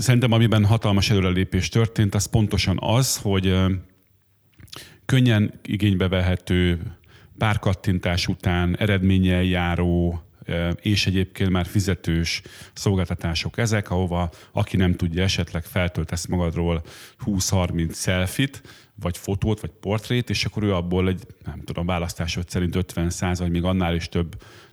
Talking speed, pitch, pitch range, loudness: 125 wpm, 95 Hz, 90-105 Hz, -23 LUFS